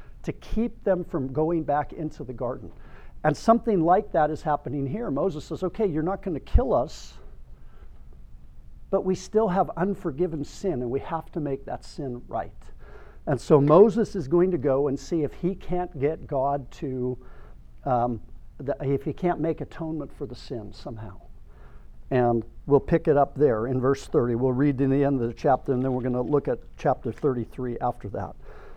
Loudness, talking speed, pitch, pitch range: -26 LUFS, 195 wpm, 140 Hz, 120-165 Hz